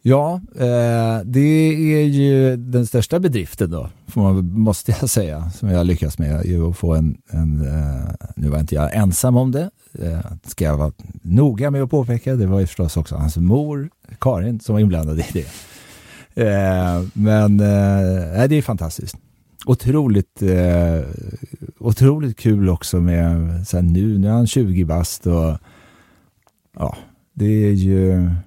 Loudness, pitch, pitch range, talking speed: -18 LUFS, 100 Hz, 85-125 Hz, 160 wpm